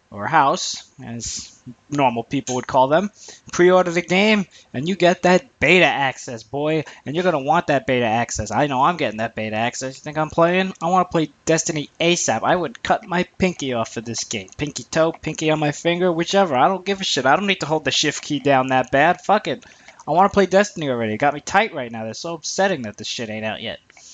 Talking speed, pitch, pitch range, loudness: 245 wpm, 155 Hz, 125-180 Hz, -19 LUFS